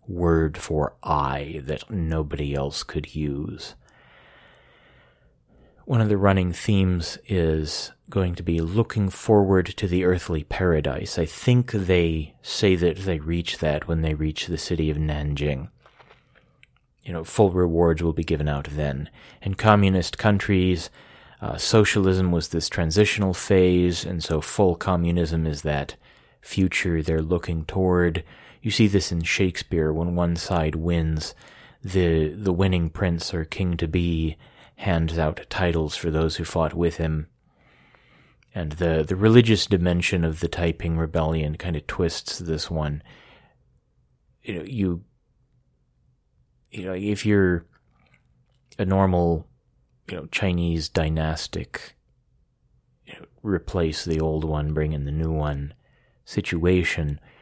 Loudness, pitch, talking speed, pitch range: -24 LUFS, 85 Hz, 135 wpm, 80-95 Hz